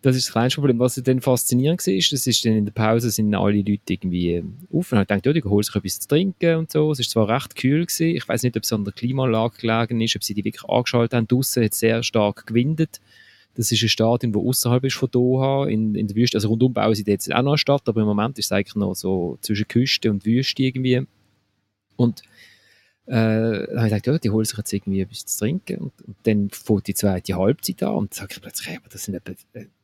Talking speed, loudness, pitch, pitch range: 260 wpm, -21 LUFS, 115 Hz, 105-130 Hz